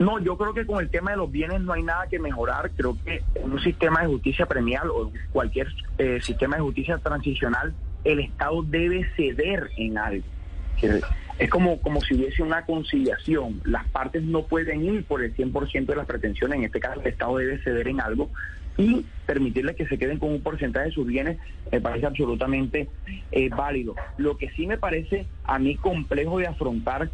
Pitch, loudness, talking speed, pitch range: 140 Hz, -26 LUFS, 195 wpm, 120-165 Hz